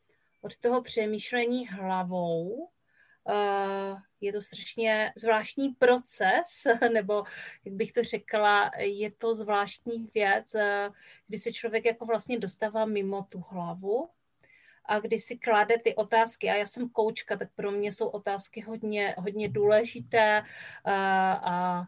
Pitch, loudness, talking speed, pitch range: 215 Hz, -29 LUFS, 135 wpm, 200-230 Hz